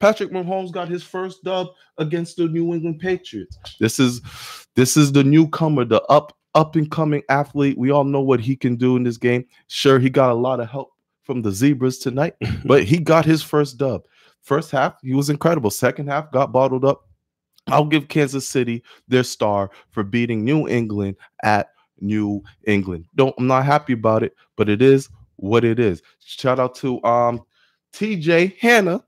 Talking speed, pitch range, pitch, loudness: 190 wpm, 120-155 Hz, 135 Hz, -19 LUFS